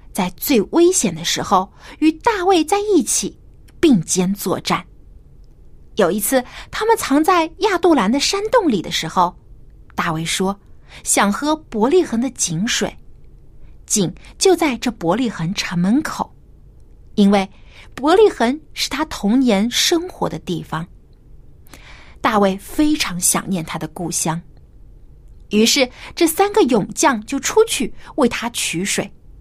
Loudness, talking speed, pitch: -17 LUFS, 190 characters per minute, 235 Hz